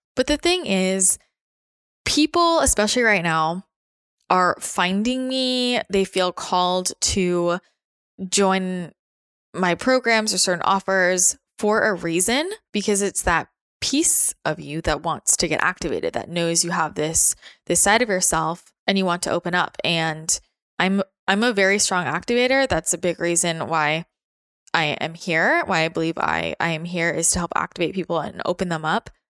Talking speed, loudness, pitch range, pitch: 165 wpm, -20 LUFS, 170-210 Hz, 185 Hz